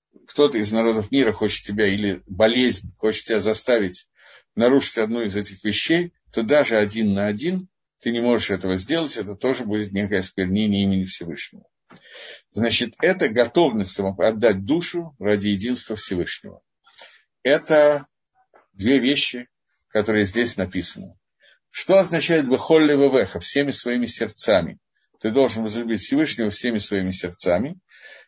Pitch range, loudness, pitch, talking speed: 105-140 Hz, -21 LUFS, 110 Hz, 130 wpm